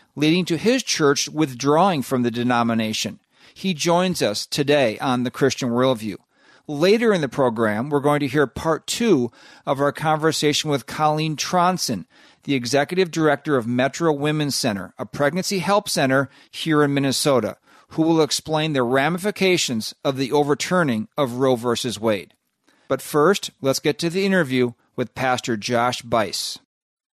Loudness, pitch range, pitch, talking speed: -21 LUFS, 125-160 Hz, 145 Hz, 155 wpm